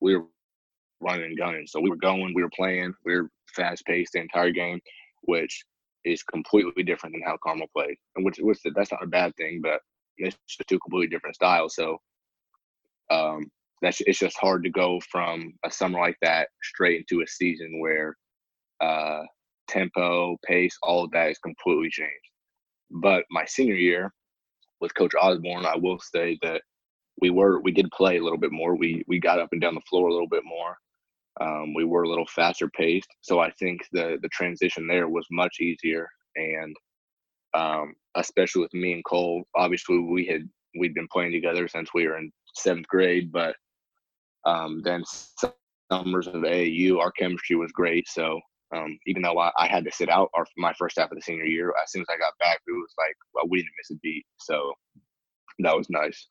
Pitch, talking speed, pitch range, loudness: 85 Hz, 195 wpm, 85-90 Hz, -26 LUFS